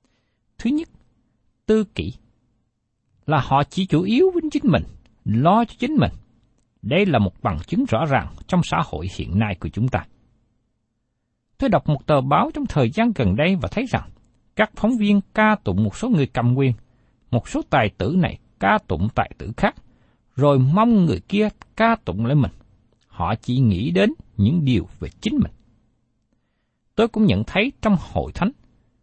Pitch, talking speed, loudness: 130 Hz, 180 wpm, -21 LUFS